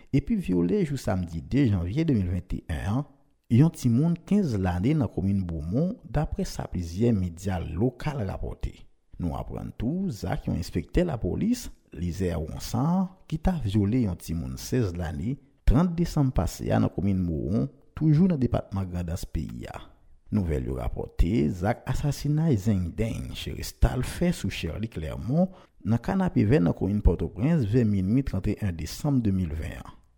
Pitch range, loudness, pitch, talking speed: 90-145 Hz, -27 LUFS, 110 Hz, 160 wpm